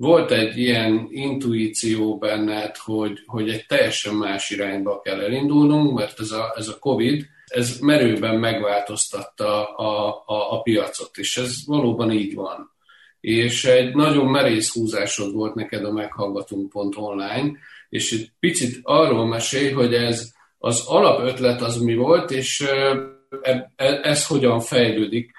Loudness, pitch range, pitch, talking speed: -21 LUFS, 105-135 Hz, 115 Hz, 135 wpm